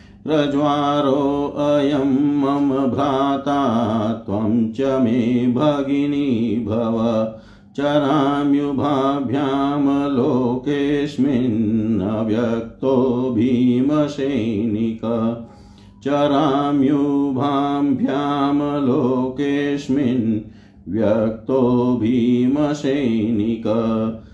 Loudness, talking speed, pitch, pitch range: -19 LUFS, 45 wpm, 135 Hz, 115-140 Hz